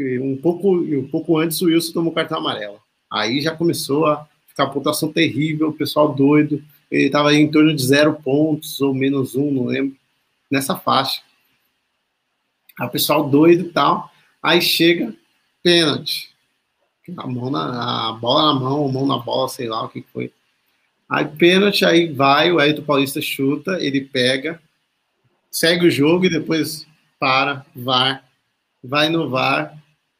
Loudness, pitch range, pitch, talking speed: -18 LUFS, 135-160 Hz, 150 Hz, 160 wpm